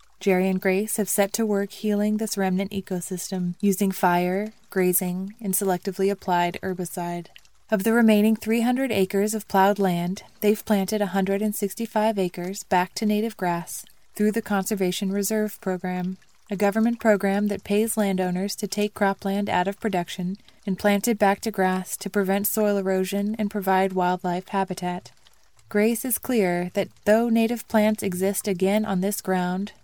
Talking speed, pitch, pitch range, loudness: 155 wpm, 200 Hz, 185-210 Hz, -24 LUFS